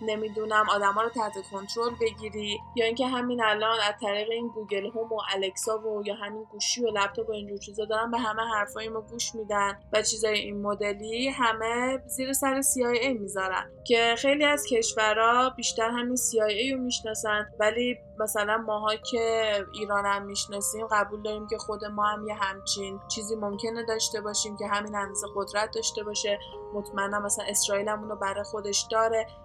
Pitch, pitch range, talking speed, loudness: 215 Hz, 205-225 Hz, 170 wpm, -28 LUFS